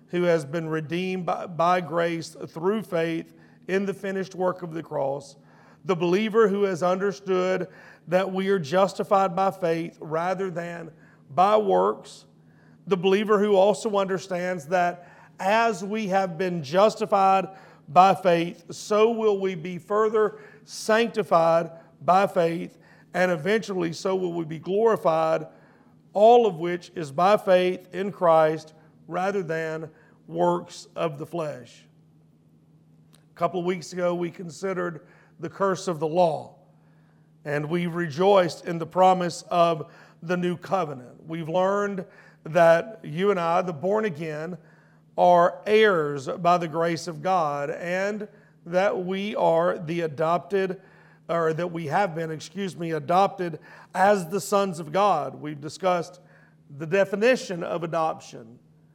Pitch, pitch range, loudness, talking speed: 175 Hz, 165-195 Hz, -24 LUFS, 140 wpm